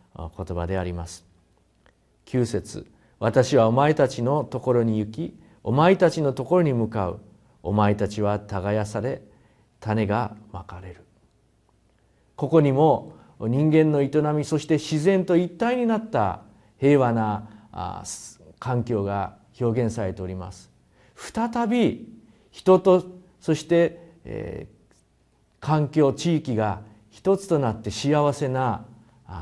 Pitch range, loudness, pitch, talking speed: 105-155 Hz, -23 LUFS, 125 Hz, 215 characters per minute